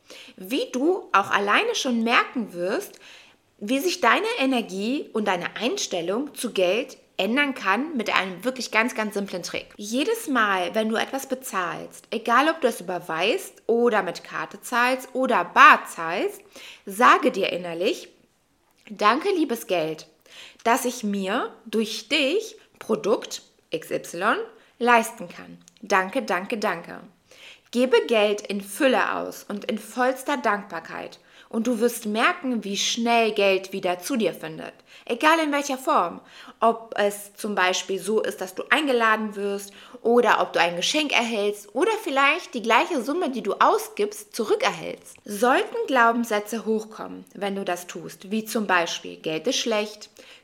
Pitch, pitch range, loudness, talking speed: 235 Hz, 200-270 Hz, -23 LUFS, 145 wpm